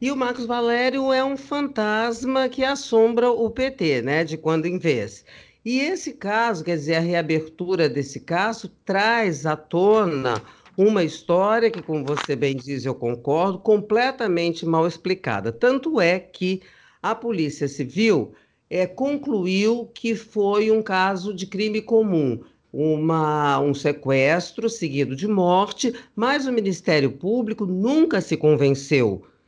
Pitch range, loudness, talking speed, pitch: 155-230 Hz, -22 LUFS, 140 wpm, 190 Hz